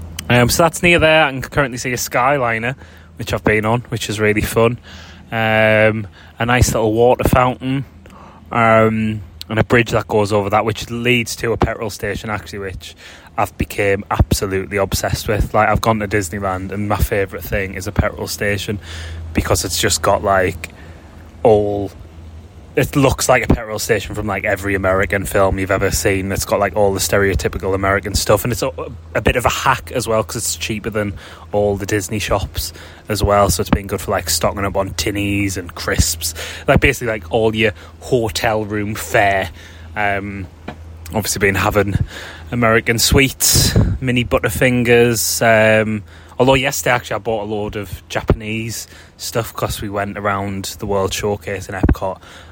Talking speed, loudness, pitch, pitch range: 175 wpm, -17 LUFS, 100 Hz, 95-110 Hz